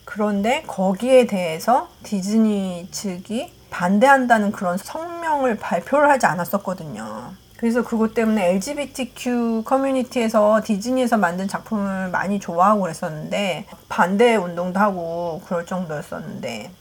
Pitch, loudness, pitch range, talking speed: 210 Hz, -20 LUFS, 185-240 Hz, 320 characters per minute